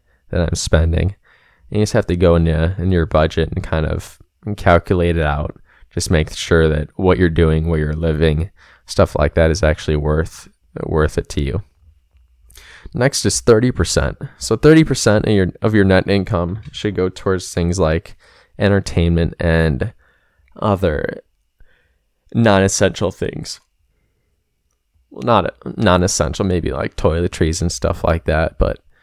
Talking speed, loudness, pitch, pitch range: 155 wpm, -17 LUFS, 85 Hz, 80-95 Hz